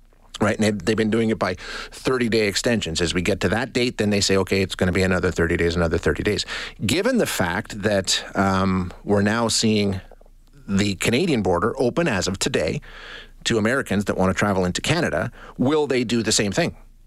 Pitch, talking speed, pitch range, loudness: 100 Hz, 205 wpm, 95-110 Hz, -21 LUFS